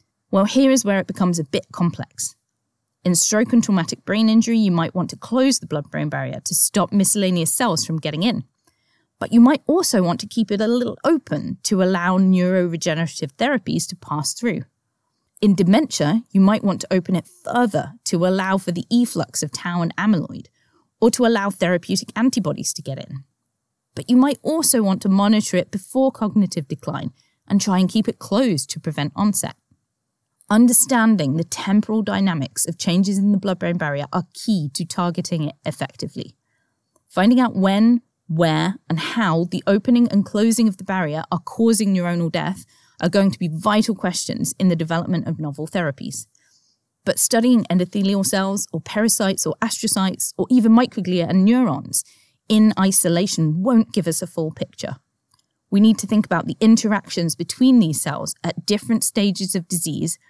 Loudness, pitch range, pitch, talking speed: -19 LUFS, 170-220 Hz, 190 Hz, 175 wpm